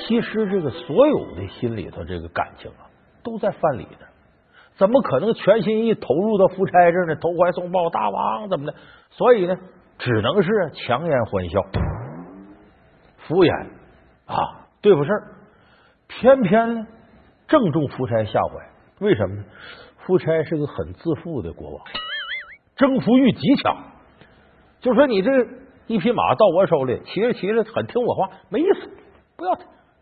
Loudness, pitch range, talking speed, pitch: -20 LUFS, 155-230 Hz, 225 characters per minute, 195 Hz